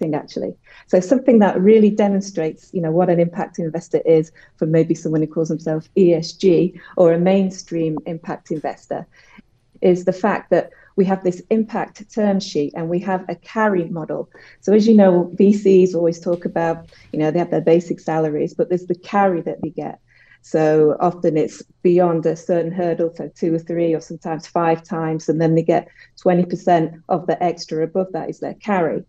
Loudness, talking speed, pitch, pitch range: -18 LUFS, 190 wpm, 170 Hz, 165-185 Hz